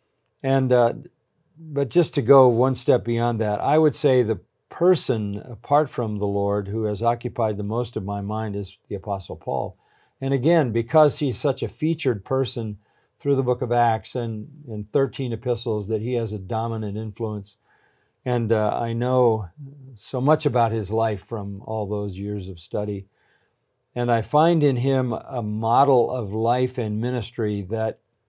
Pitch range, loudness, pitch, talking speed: 105-135 Hz, -23 LUFS, 115 Hz, 170 wpm